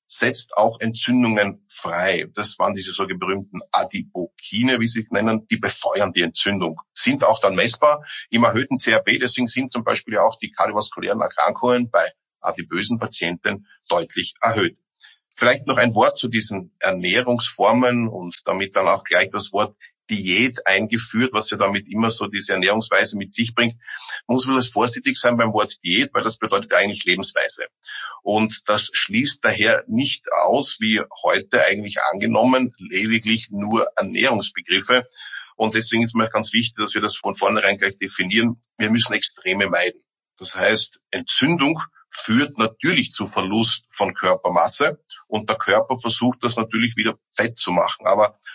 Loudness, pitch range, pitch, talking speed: -19 LUFS, 110-120 Hz, 115 Hz, 160 wpm